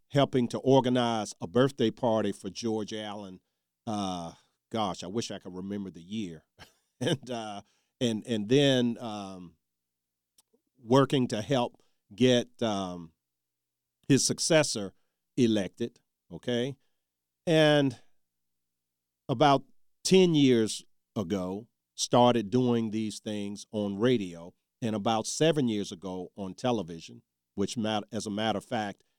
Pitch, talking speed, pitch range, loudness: 105 Hz, 120 wpm, 90-120 Hz, -29 LUFS